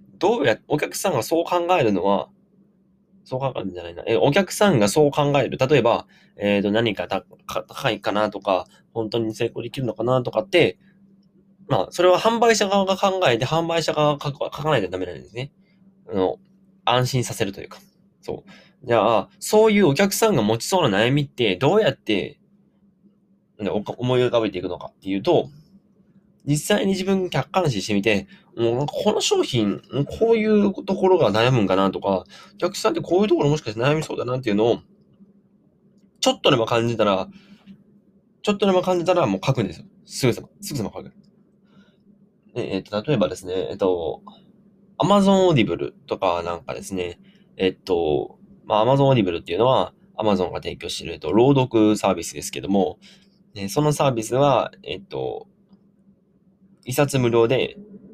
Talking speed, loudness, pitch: 365 characters per minute, -21 LUFS, 180 Hz